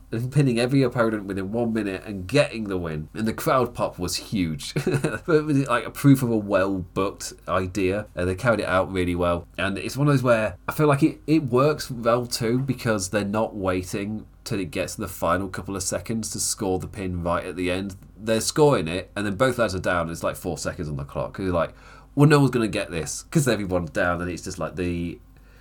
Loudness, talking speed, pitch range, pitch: -24 LUFS, 240 wpm, 90-120 Hz, 105 Hz